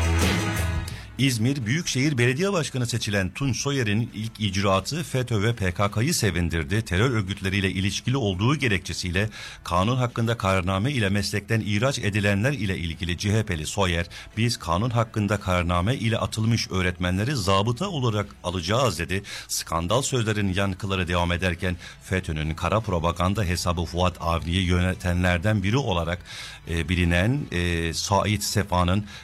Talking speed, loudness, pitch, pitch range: 120 wpm, -24 LUFS, 100 Hz, 90-115 Hz